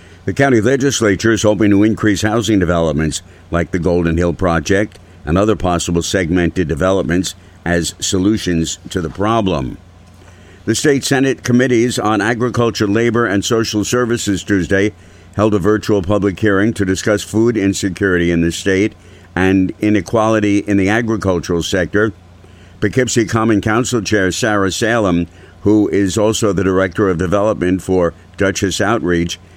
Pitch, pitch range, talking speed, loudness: 100 Hz, 90-110 Hz, 140 wpm, -15 LUFS